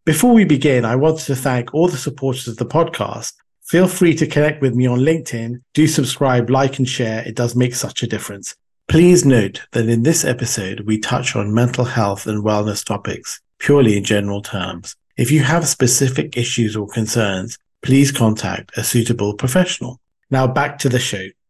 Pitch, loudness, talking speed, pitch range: 125 Hz, -17 LUFS, 185 wpm, 110-145 Hz